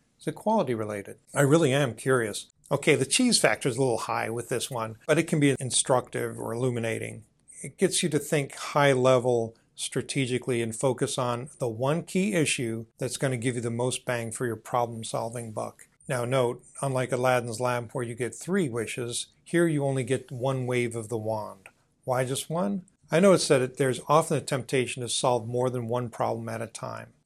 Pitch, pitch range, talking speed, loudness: 130 Hz, 120-140 Hz, 205 wpm, -27 LUFS